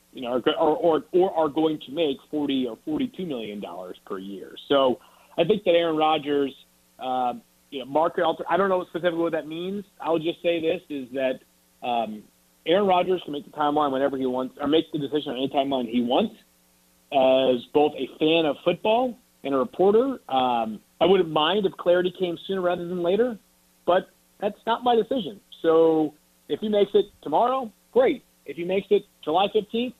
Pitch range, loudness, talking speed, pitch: 130-190 Hz, -24 LUFS, 190 wpm, 160 Hz